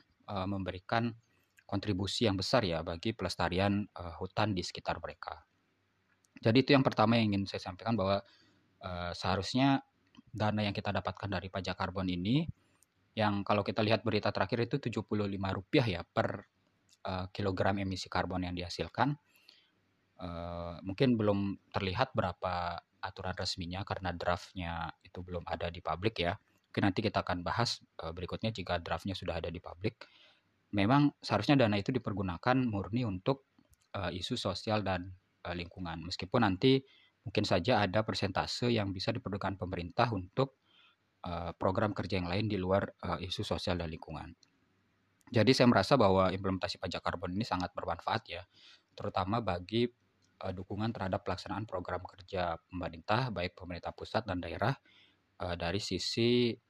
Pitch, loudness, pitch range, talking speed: 95 Hz, -34 LUFS, 90-110 Hz, 135 wpm